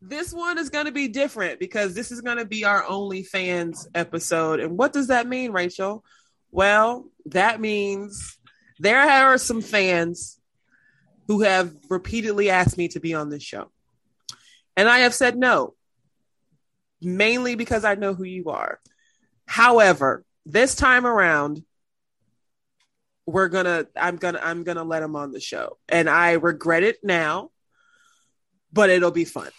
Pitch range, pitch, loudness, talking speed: 170-245 Hz, 200 Hz, -21 LUFS, 160 wpm